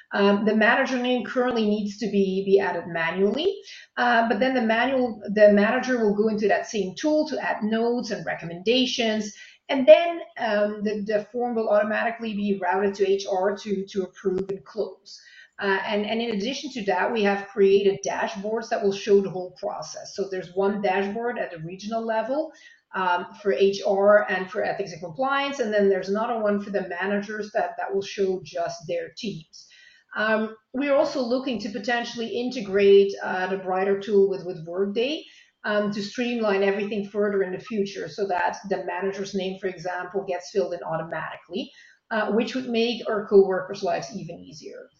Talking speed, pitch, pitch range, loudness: 180 wpm, 205 Hz, 195-235 Hz, -24 LUFS